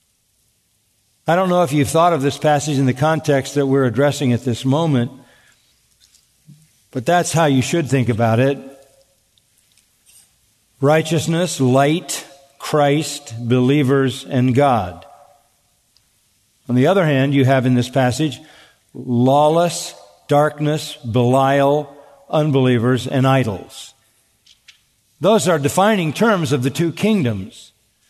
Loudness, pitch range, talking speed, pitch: -17 LUFS, 120-150 Hz, 115 wpm, 135 Hz